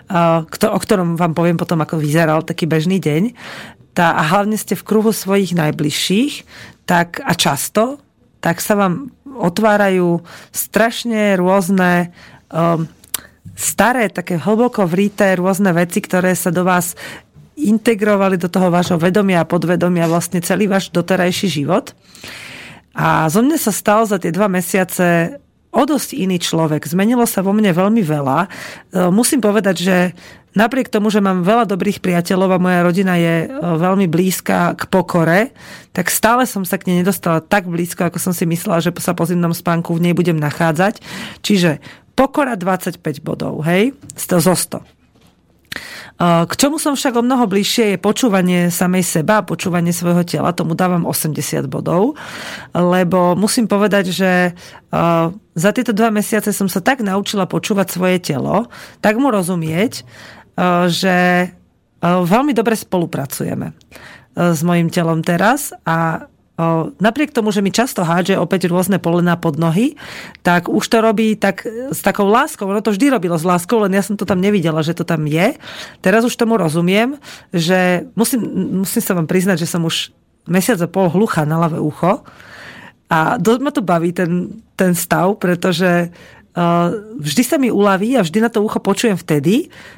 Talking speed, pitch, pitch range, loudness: 160 wpm, 185 Hz, 170-210 Hz, -16 LUFS